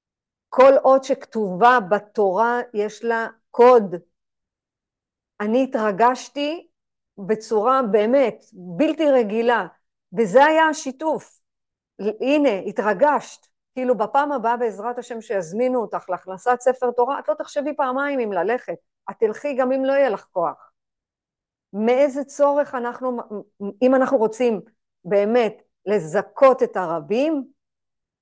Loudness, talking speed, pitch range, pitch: -20 LUFS, 110 wpm, 210-270 Hz, 240 Hz